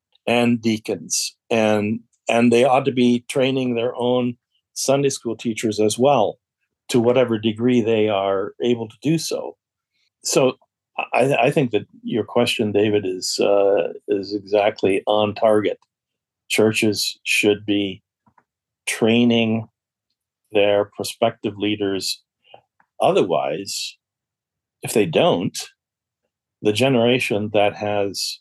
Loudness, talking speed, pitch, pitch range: -20 LUFS, 115 wpm, 115 Hz, 105-120 Hz